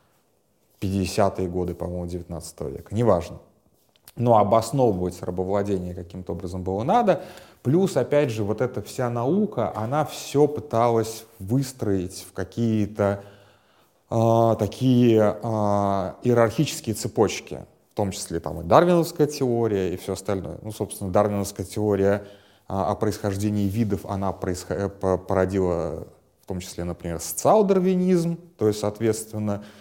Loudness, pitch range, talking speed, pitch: -24 LUFS, 95-120 Hz, 120 wpm, 105 Hz